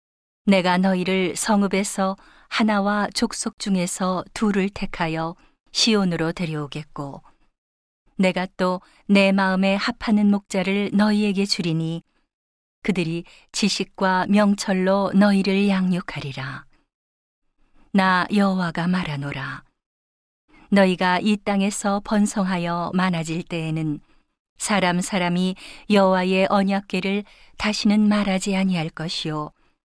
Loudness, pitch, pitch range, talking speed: -21 LUFS, 190 Hz, 175-200 Hz, 240 characters per minute